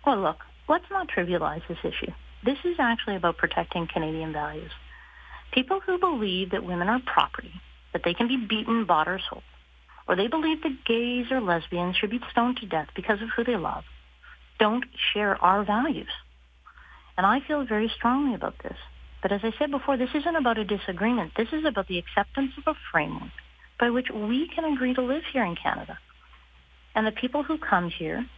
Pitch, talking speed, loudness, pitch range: 220 Hz, 190 wpm, -27 LUFS, 175-265 Hz